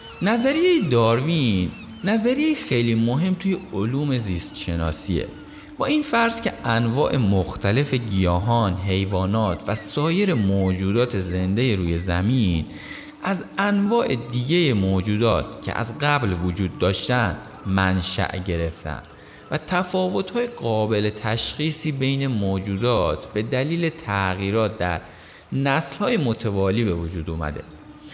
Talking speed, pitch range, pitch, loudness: 105 wpm, 95-150 Hz, 110 Hz, -22 LUFS